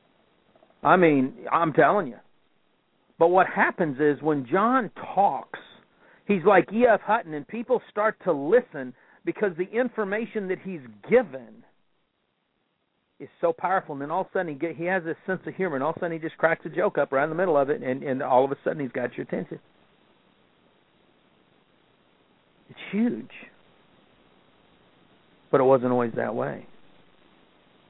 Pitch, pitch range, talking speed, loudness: 170 Hz, 145-205 Hz, 170 wpm, -25 LUFS